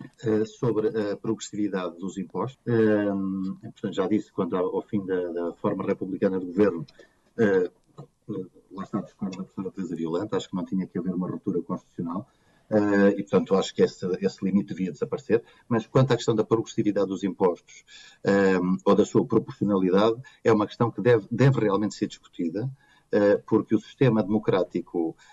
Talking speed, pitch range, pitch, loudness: 175 wpm, 95-110 Hz, 105 Hz, -26 LUFS